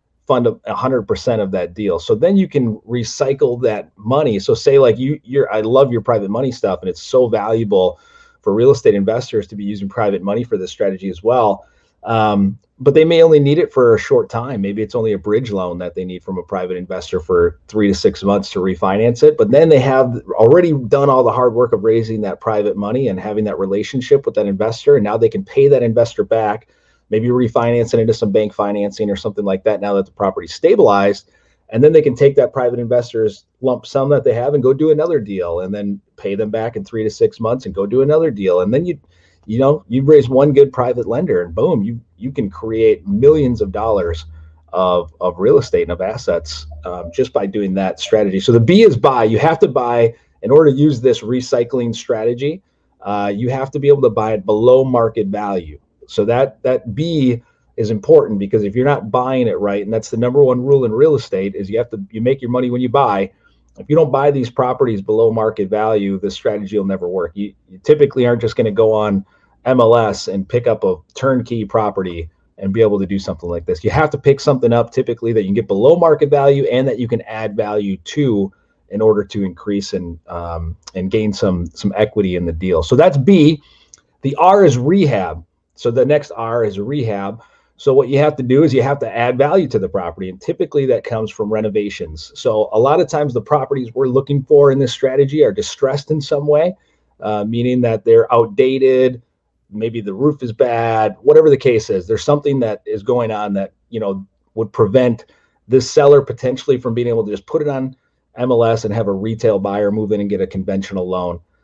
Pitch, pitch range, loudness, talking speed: 115 Hz, 100-145 Hz, -15 LUFS, 225 wpm